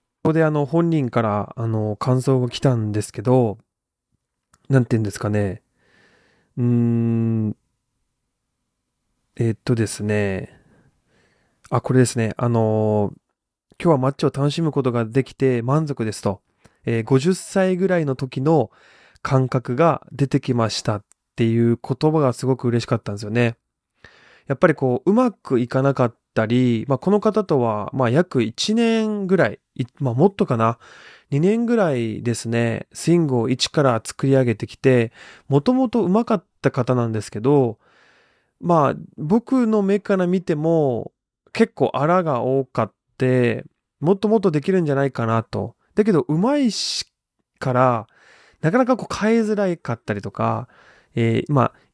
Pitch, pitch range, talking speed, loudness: 130 Hz, 115-165 Hz, 285 characters per minute, -20 LUFS